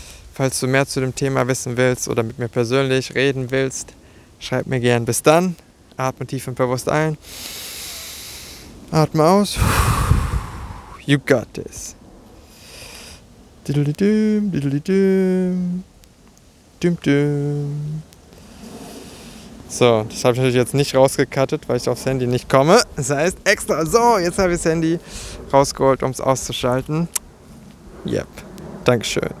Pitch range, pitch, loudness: 125-160 Hz, 135 Hz, -19 LUFS